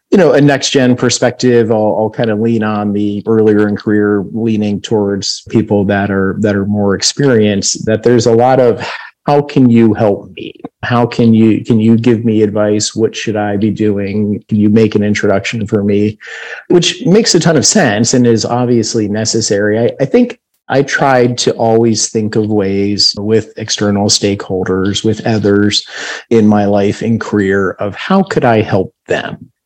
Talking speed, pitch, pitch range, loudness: 180 wpm, 110 Hz, 105-120 Hz, -11 LUFS